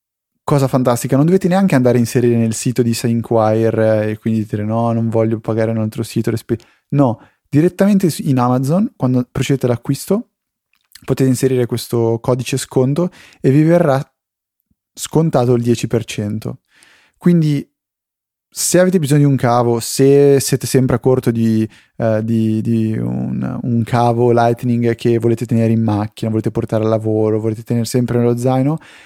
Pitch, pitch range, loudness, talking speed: 120 Hz, 115-135 Hz, -15 LUFS, 155 wpm